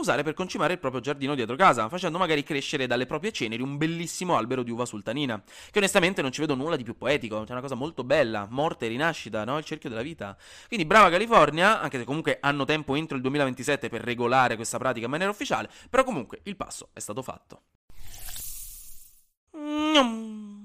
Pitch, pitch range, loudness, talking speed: 145 Hz, 125-175 Hz, -26 LUFS, 200 wpm